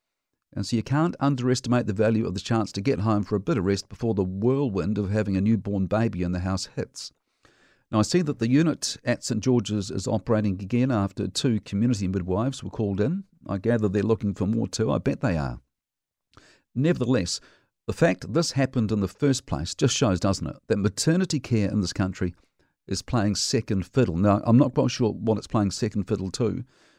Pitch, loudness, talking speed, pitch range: 110 Hz, -25 LUFS, 210 wpm, 100-125 Hz